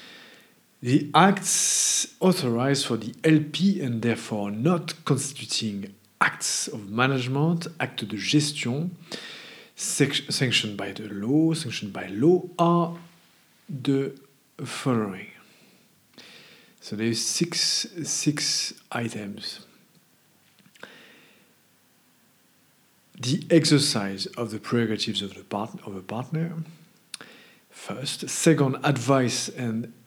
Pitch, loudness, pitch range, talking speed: 140 Hz, -25 LUFS, 115-165 Hz, 90 wpm